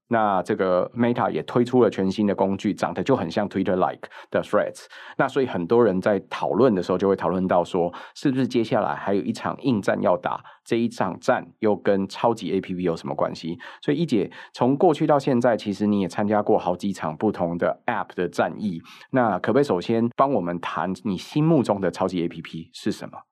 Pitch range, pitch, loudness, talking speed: 90-115 Hz, 100 Hz, -23 LUFS, 365 characters per minute